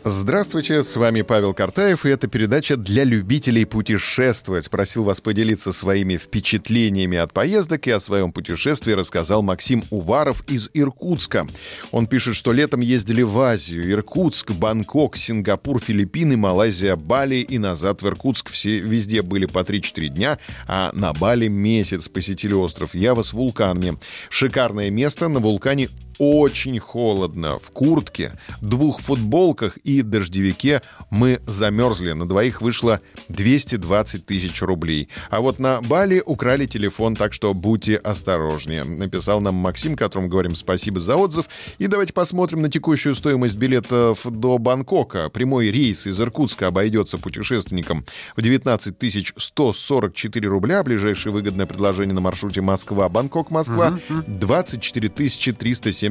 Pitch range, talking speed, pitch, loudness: 95-130 Hz, 135 wpm, 110 Hz, -20 LUFS